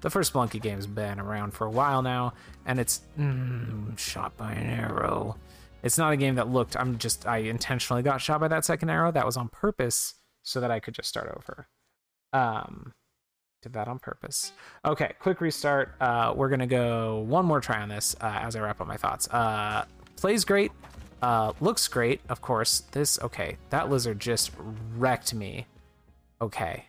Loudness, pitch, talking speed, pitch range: -28 LUFS, 120 Hz, 185 wpm, 105-135 Hz